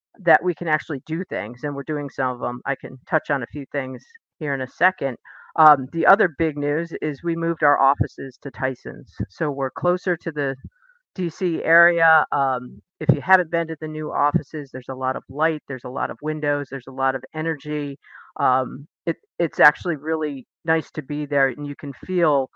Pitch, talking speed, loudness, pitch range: 150 Hz, 210 wpm, -22 LUFS, 135-165 Hz